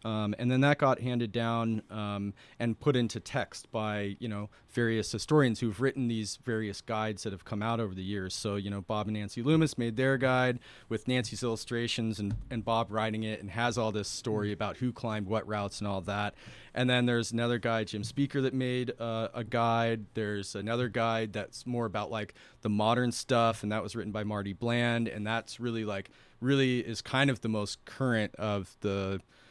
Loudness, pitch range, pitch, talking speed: -32 LUFS, 105-120 Hz, 115 Hz, 205 wpm